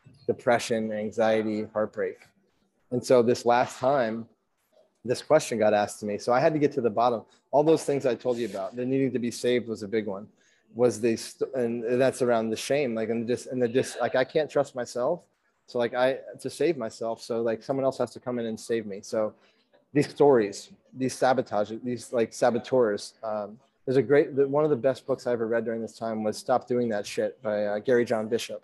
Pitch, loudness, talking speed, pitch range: 120 Hz, -27 LUFS, 230 wpm, 110-130 Hz